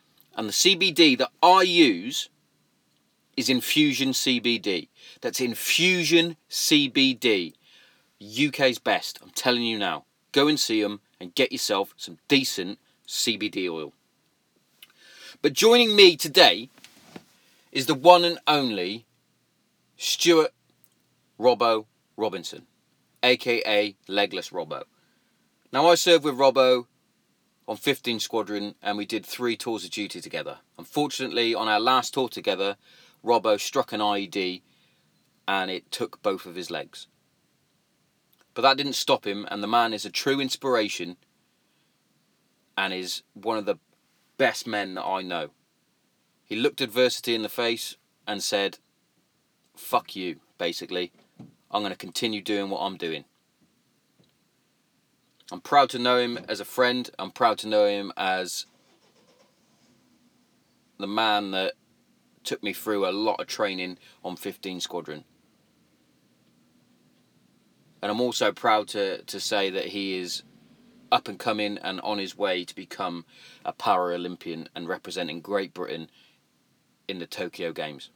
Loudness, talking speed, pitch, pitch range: -24 LUFS, 135 wpm, 120 Hz, 105-150 Hz